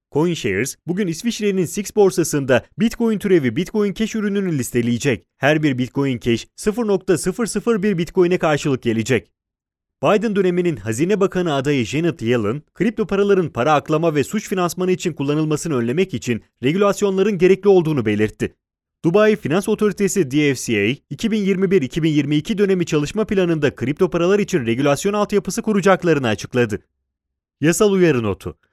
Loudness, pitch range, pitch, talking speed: -19 LUFS, 130-200 Hz, 170 Hz, 125 wpm